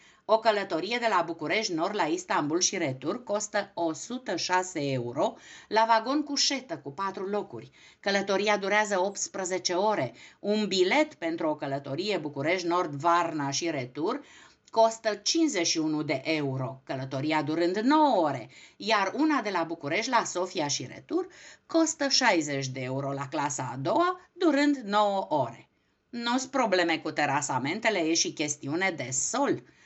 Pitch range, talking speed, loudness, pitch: 160-240 Hz, 145 wpm, -28 LUFS, 195 Hz